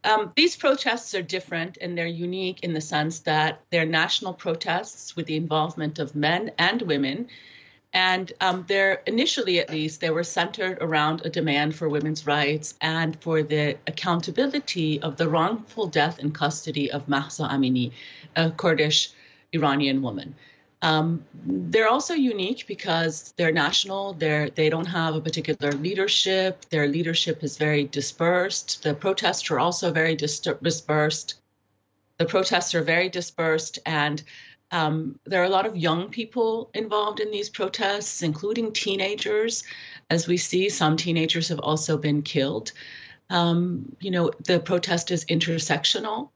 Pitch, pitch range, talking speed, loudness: 165 Hz, 155-190 Hz, 150 wpm, -24 LUFS